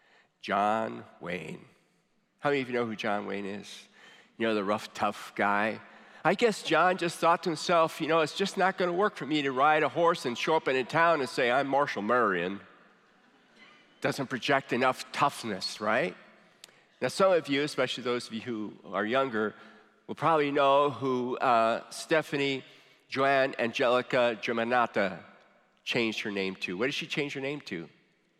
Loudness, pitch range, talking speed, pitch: -28 LUFS, 115-160 Hz, 180 wpm, 135 Hz